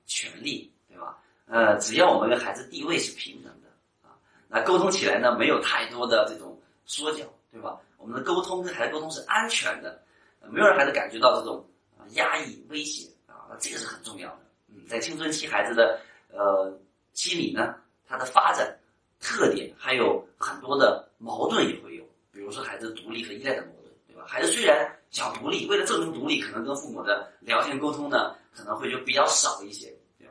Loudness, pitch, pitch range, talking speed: -26 LUFS, 145 Hz, 110-160 Hz, 295 characters per minute